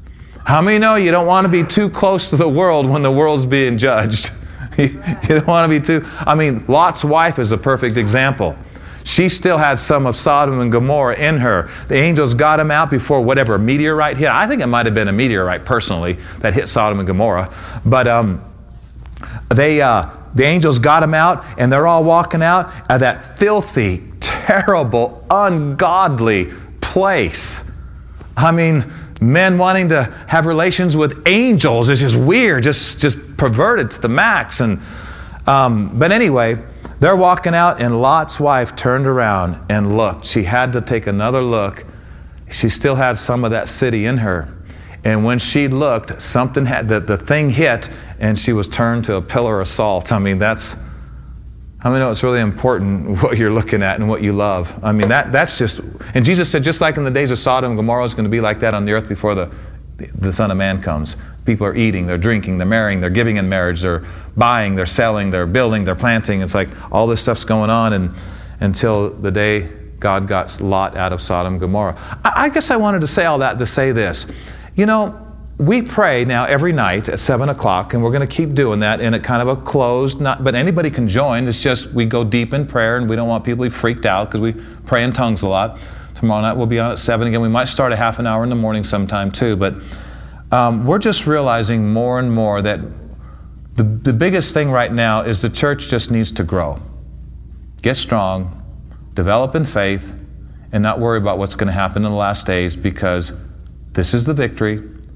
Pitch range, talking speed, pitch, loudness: 100-140 Hz, 210 wpm, 115 Hz, -15 LUFS